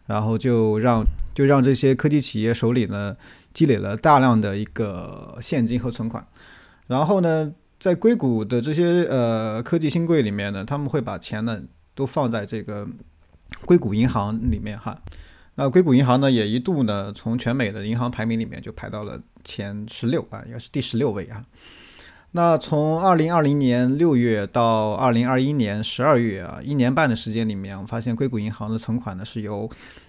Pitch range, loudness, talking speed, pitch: 105-135 Hz, -21 LUFS, 275 characters per minute, 115 Hz